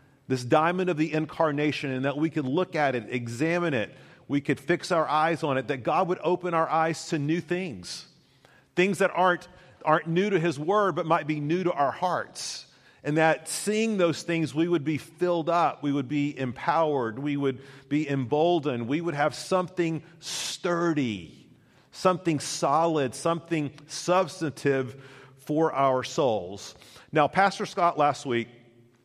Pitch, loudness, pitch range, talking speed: 155 Hz, -26 LUFS, 140-170 Hz, 165 wpm